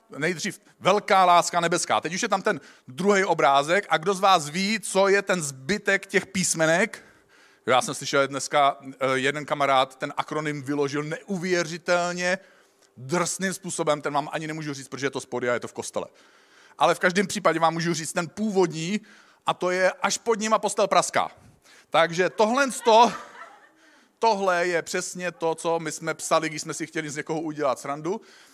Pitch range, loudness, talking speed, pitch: 150-195 Hz, -24 LUFS, 175 wpm, 170 Hz